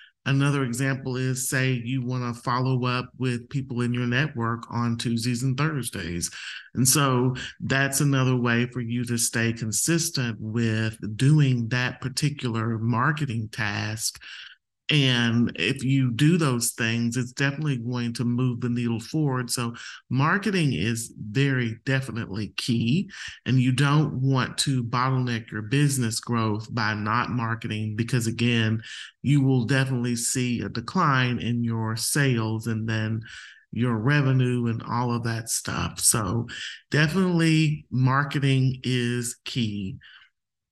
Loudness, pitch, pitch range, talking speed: -25 LUFS, 125 Hz, 115-135 Hz, 135 wpm